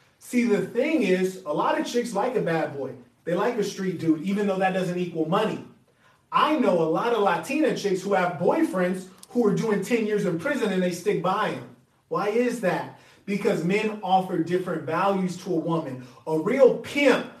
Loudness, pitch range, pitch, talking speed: -25 LUFS, 175-215 Hz, 190 Hz, 205 wpm